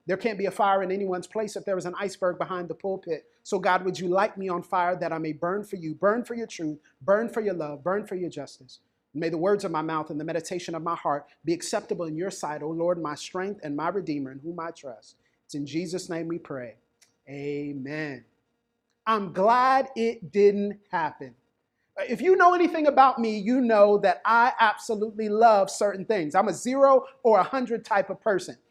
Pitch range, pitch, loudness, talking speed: 165-220 Hz, 190 Hz, -26 LUFS, 225 wpm